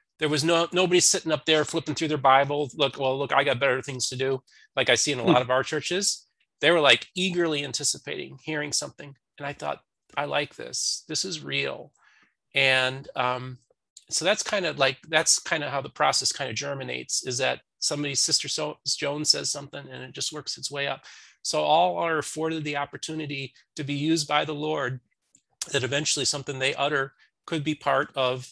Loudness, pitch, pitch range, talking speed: -25 LUFS, 145 Hz, 135-155 Hz, 205 wpm